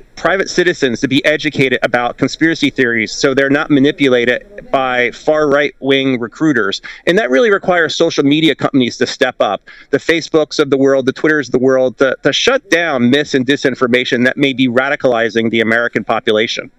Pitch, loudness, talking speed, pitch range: 135 Hz, -13 LUFS, 180 wpm, 125-150 Hz